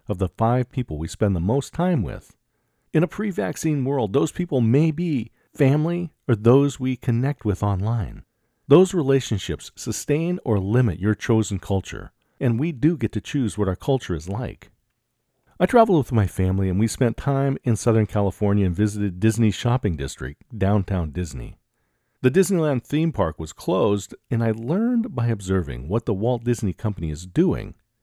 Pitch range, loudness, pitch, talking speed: 100-140 Hz, -22 LUFS, 115 Hz, 175 wpm